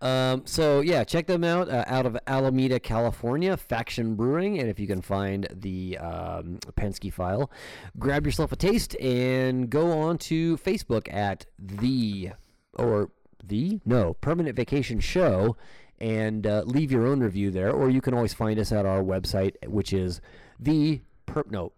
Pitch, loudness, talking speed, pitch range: 120 Hz, -26 LUFS, 165 wpm, 100-140 Hz